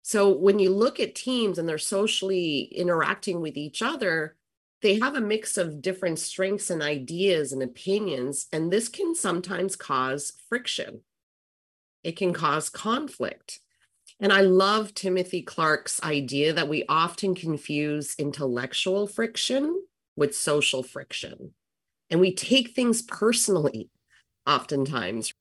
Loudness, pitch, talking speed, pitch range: -25 LUFS, 180 Hz, 130 wpm, 150-200 Hz